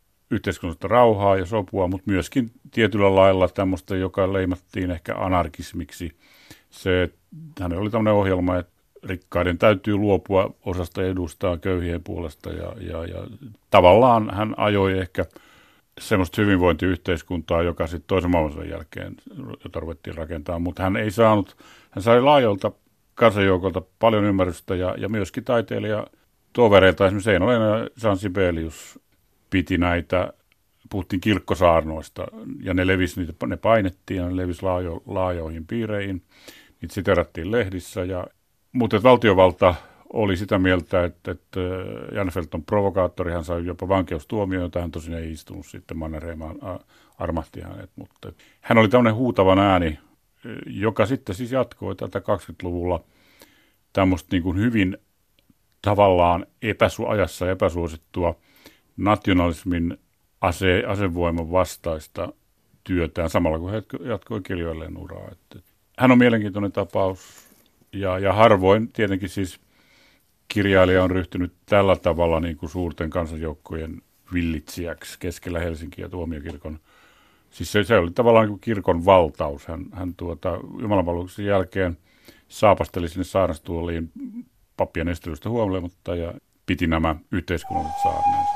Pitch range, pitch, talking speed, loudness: 85-105 Hz, 95 Hz, 120 wpm, -22 LUFS